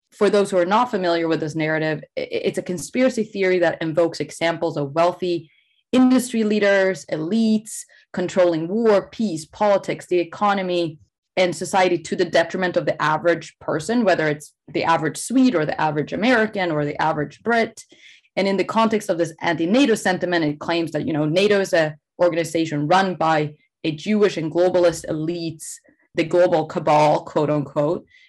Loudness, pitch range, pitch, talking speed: -20 LUFS, 160-200 Hz, 175 Hz, 165 wpm